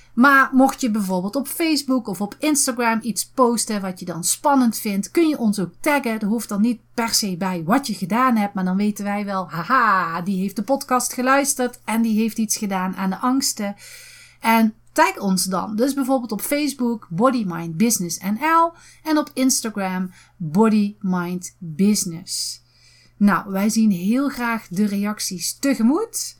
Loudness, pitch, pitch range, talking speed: -20 LUFS, 220 Hz, 195-260 Hz, 165 wpm